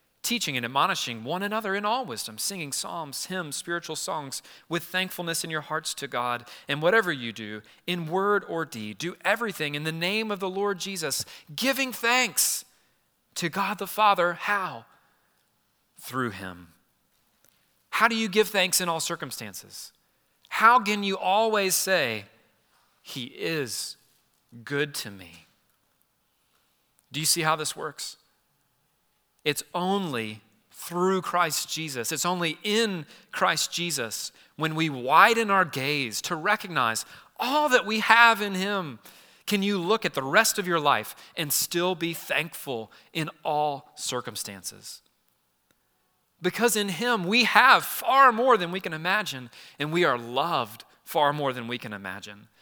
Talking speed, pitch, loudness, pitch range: 150 wpm, 170 Hz, -25 LUFS, 135-200 Hz